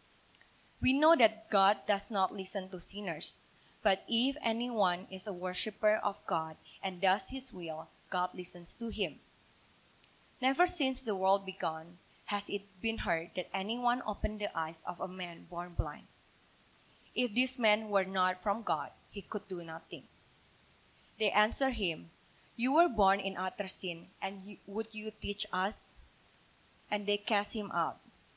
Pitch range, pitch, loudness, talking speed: 185-220 Hz, 200 Hz, -33 LUFS, 155 wpm